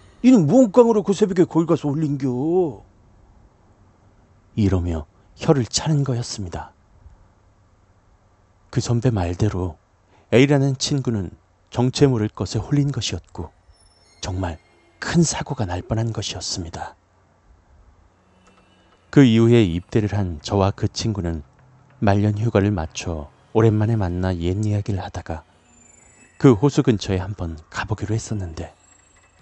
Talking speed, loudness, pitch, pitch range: 240 characters per minute, -20 LUFS, 100 Hz, 90-120 Hz